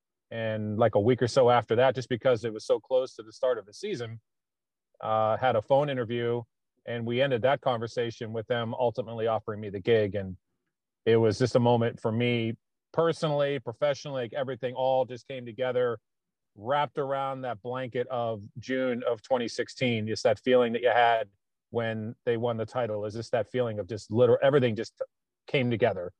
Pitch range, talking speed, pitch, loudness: 115-130 Hz, 190 wpm, 120 Hz, -28 LUFS